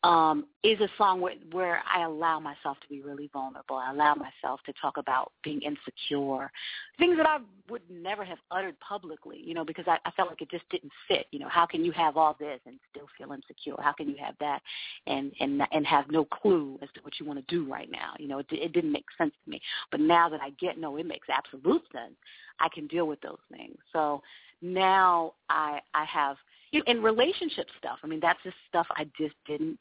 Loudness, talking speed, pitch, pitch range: -29 LUFS, 230 wpm, 160 Hz, 145-185 Hz